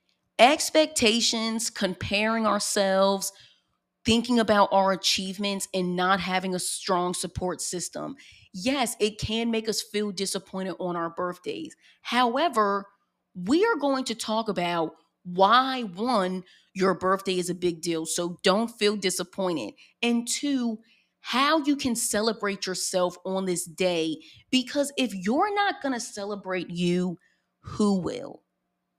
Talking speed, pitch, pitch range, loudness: 130 wpm, 200 Hz, 180-230 Hz, -26 LUFS